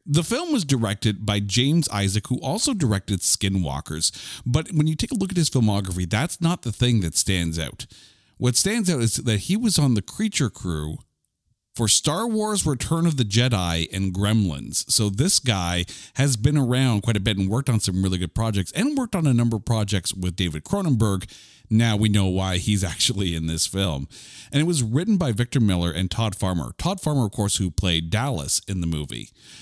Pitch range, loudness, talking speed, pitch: 95-135 Hz, -22 LUFS, 205 wpm, 110 Hz